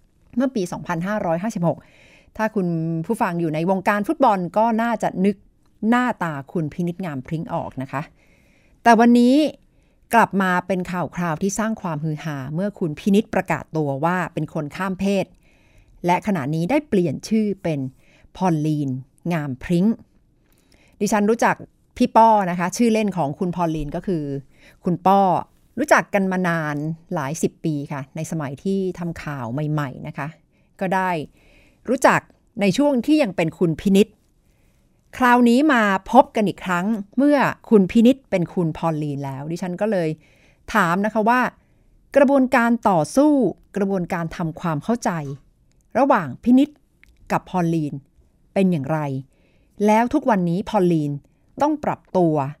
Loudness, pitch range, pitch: -21 LUFS, 160-220 Hz, 180 Hz